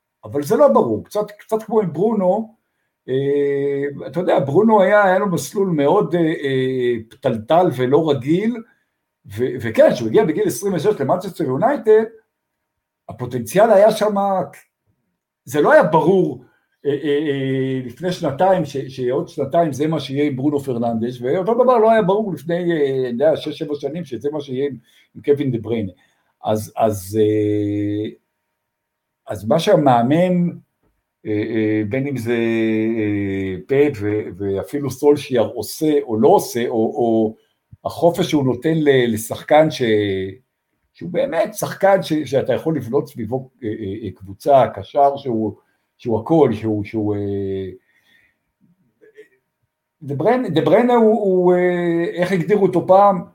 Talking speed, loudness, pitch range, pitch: 145 wpm, -18 LUFS, 115-180 Hz, 145 Hz